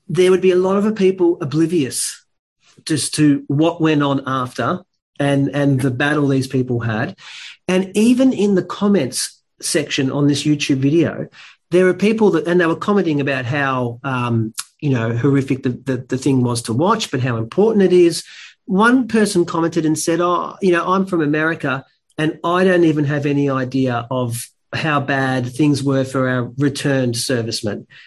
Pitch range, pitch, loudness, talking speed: 130-175 Hz, 145 Hz, -17 LUFS, 180 wpm